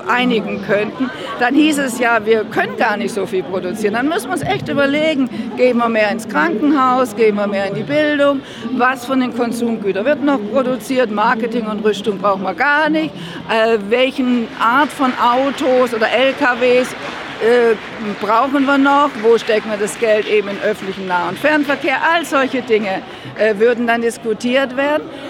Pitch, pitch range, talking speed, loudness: 240 Hz, 215-270 Hz, 170 wpm, -16 LUFS